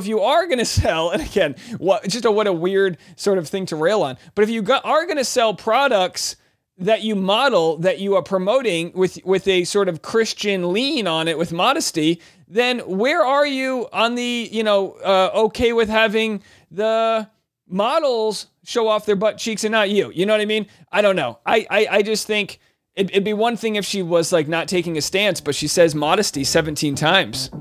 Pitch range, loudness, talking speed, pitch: 175-220 Hz, -19 LUFS, 220 wpm, 200 Hz